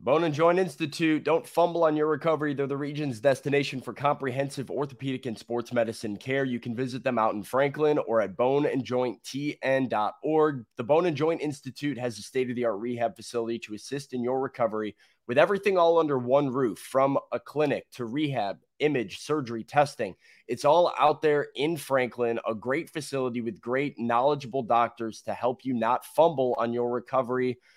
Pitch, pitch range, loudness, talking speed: 135 Hz, 120-150 Hz, -27 LUFS, 180 wpm